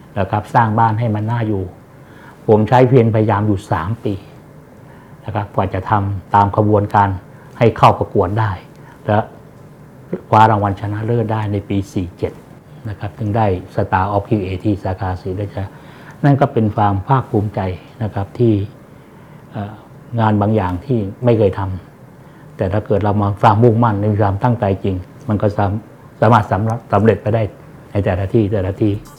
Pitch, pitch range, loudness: 110 Hz, 100-120 Hz, -16 LUFS